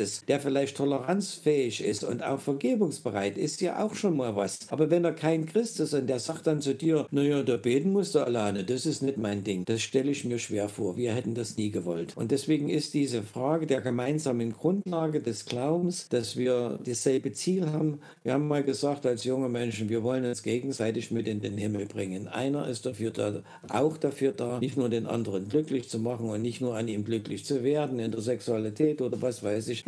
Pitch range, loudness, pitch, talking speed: 115-150 Hz, -29 LUFS, 130 Hz, 215 wpm